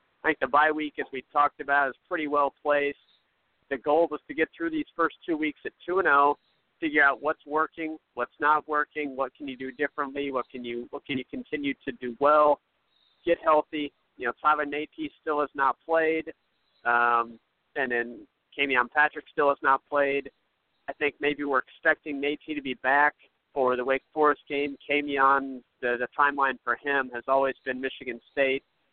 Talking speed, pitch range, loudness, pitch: 195 wpm, 135-150 Hz, -27 LUFS, 145 Hz